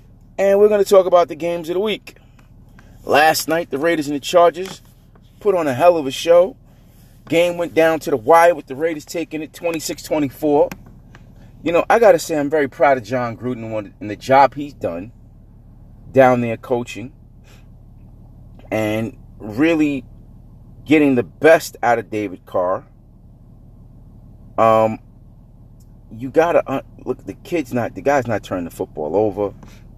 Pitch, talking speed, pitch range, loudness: 125 Hz, 165 wpm, 115-160 Hz, -17 LUFS